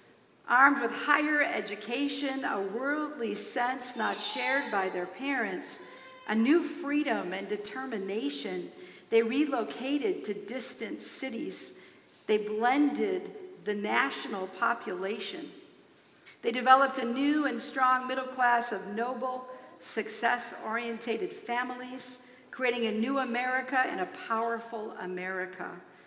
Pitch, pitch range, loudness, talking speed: 250 Hz, 220-270 Hz, -29 LUFS, 110 wpm